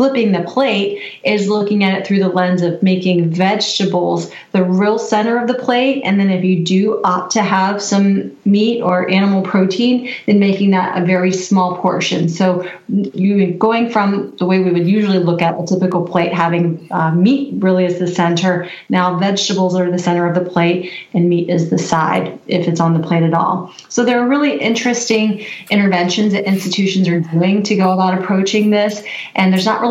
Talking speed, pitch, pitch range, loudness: 200 wpm, 190 Hz, 180-205 Hz, -15 LUFS